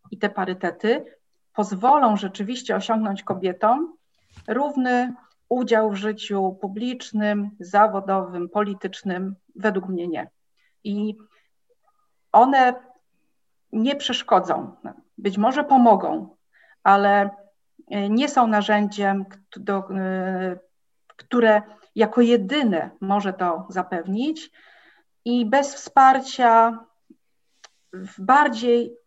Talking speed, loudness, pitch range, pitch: 80 wpm, -21 LUFS, 195-245 Hz, 215 Hz